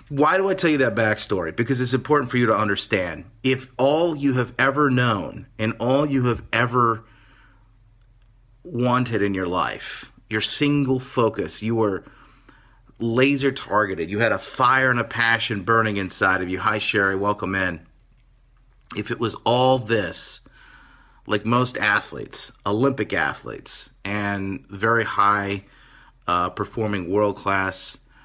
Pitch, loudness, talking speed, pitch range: 115 Hz, -22 LUFS, 145 wpm, 105-130 Hz